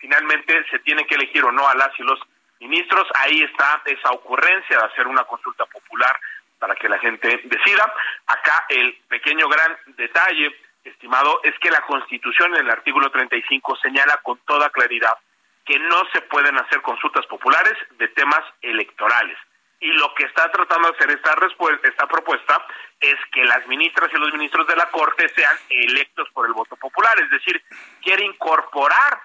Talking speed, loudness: 175 wpm, -17 LUFS